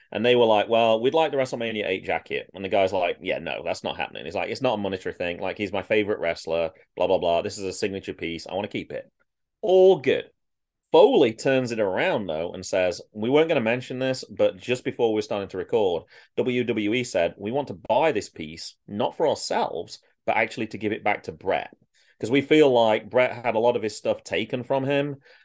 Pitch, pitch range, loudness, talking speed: 120 Hz, 105-140 Hz, -24 LUFS, 235 wpm